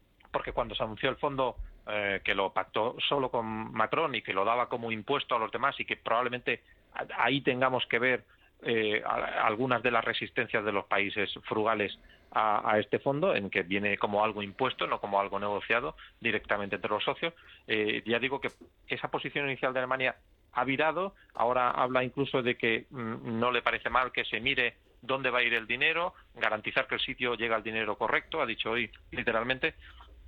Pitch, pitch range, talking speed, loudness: 120 Hz, 110-130 Hz, 195 wpm, -30 LUFS